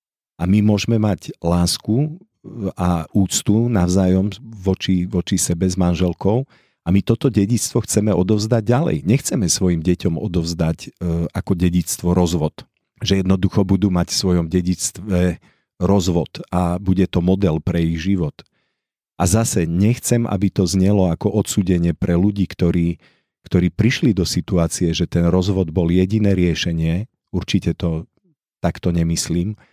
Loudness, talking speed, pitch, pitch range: -19 LUFS, 135 wpm, 95 Hz, 85-105 Hz